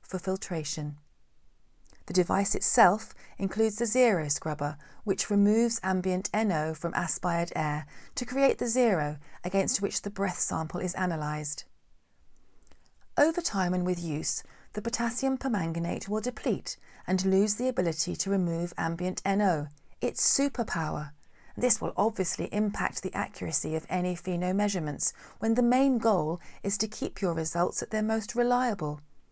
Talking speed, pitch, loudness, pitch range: 145 wpm, 190 Hz, -27 LUFS, 165-220 Hz